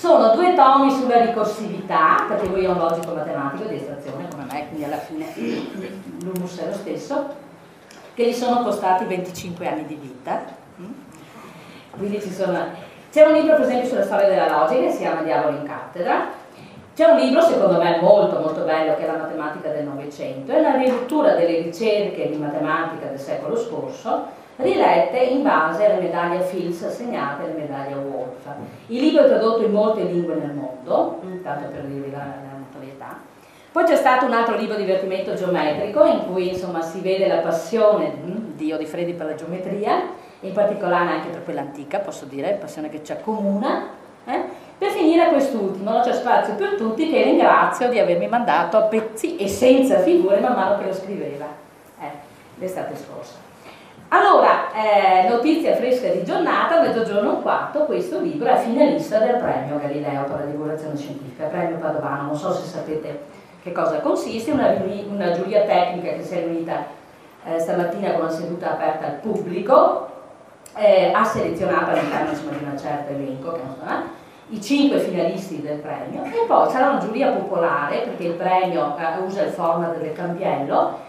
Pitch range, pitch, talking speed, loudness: 155-240 Hz, 185 Hz, 170 wpm, -20 LUFS